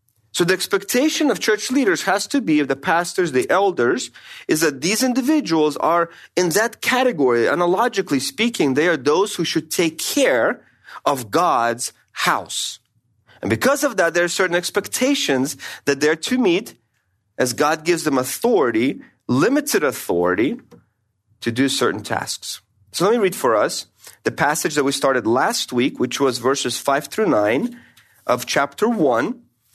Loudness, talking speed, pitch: -19 LUFS, 160 wpm, 170 Hz